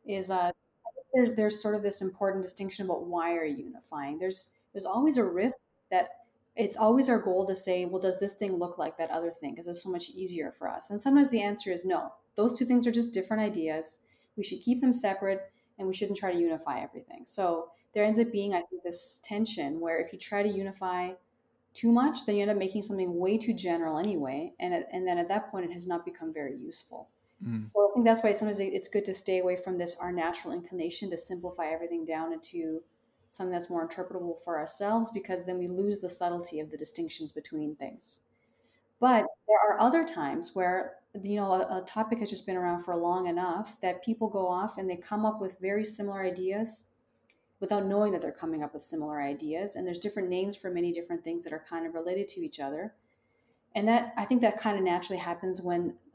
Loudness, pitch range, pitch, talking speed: -31 LUFS, 175-215 Hz, 190 Hz, 225 wpm